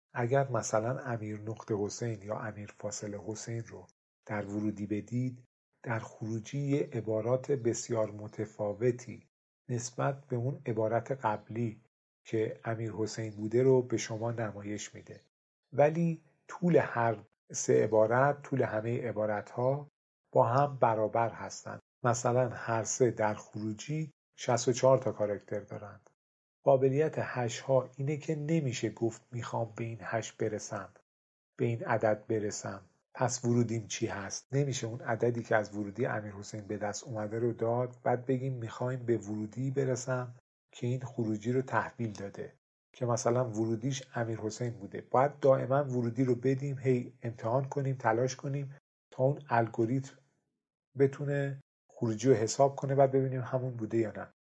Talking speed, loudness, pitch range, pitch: 145 wpm, -33 LUFS, 110-130 Hz, 120 Hz